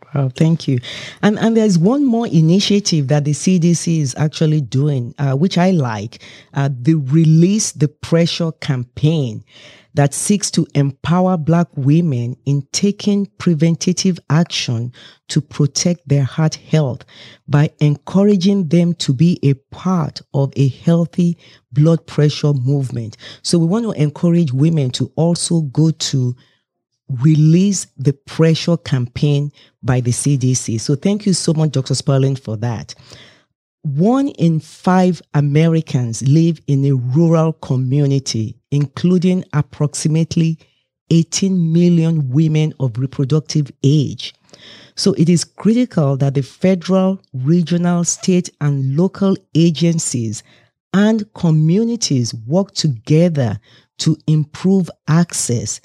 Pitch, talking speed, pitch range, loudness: 155 Hz, 125 wpm, 135-170 Hz, -16 LUFS